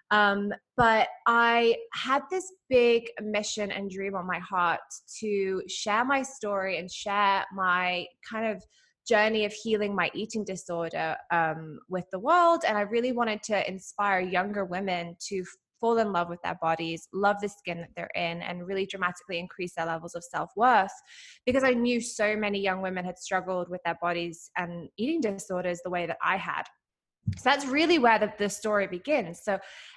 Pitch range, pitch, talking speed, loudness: 180-225 Hz, 200 Hz, 185 wpm, -28 LUFS